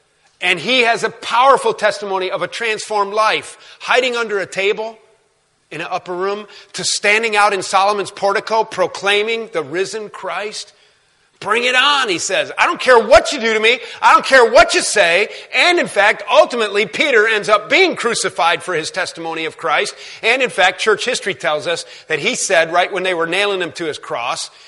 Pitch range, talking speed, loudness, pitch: 190-235 Hz, 195 wpm, -15 LUFS, 210 Hz